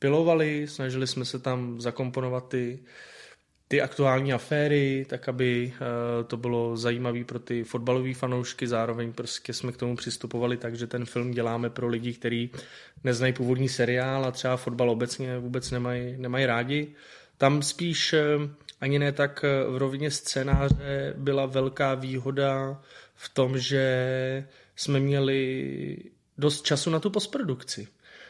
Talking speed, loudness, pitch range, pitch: 140 wpm, -28 LUFS, 120-140 Hz, 130 Hz